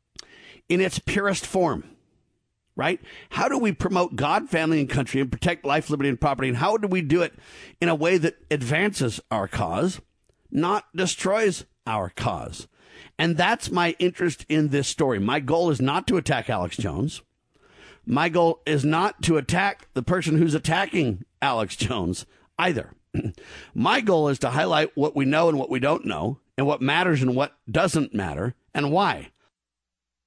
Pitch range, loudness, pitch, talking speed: 135-175 Hz, -24 LUFS, 155 Hz, 170 wpm